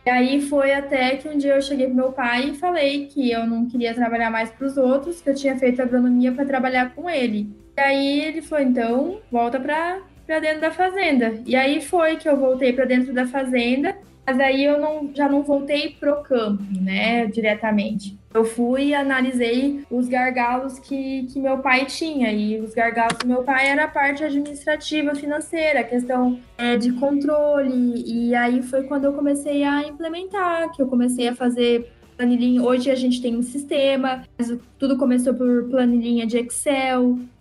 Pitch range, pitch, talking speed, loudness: 245-285 Hz, 260 Hz, 190 wpm, -21 LUFS